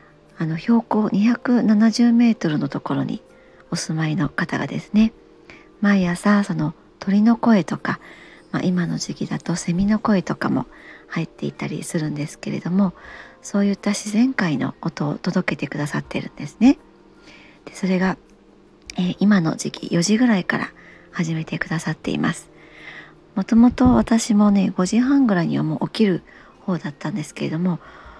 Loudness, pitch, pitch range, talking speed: -21 LUFS, 185 Hz, 165-215 Hz, 300 characters per minute